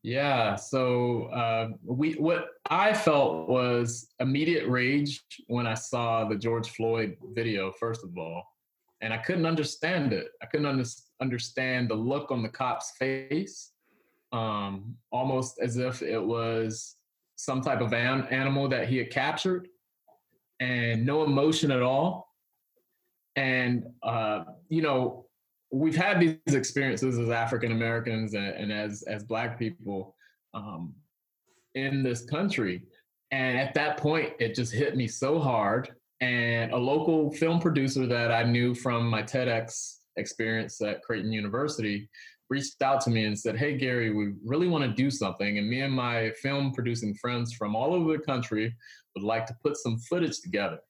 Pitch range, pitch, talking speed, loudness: 115-140 Hz, 125 Hz, 160 wpm, -29 LUFS